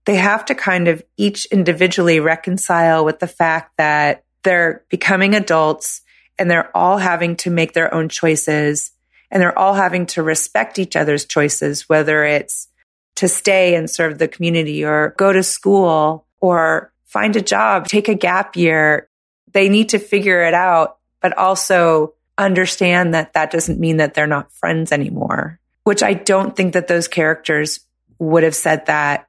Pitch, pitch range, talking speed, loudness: 170 Hz, 155-190 Hz, 170 wpm, -15 LUFS